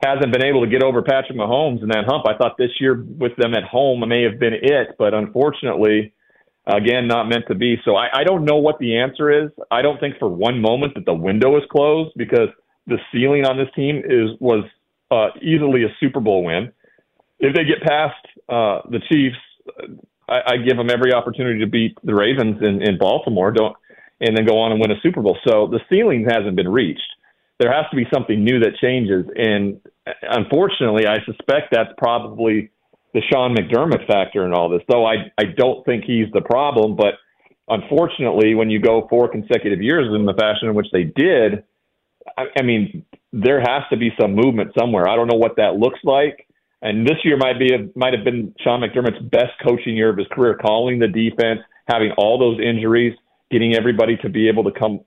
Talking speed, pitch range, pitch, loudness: 210 wpm, 110-130 Hz, 120 Hz, -17 LUFS